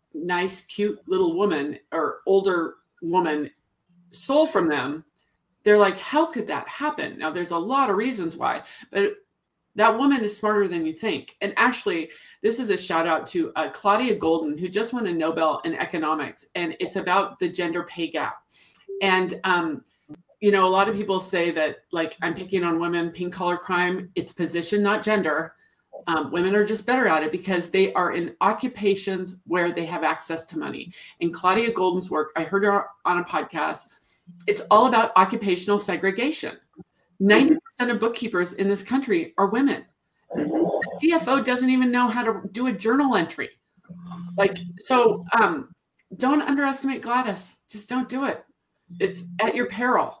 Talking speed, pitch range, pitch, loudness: 175 wpm, 175-245 Hz, 195 Hz, -23 LUFS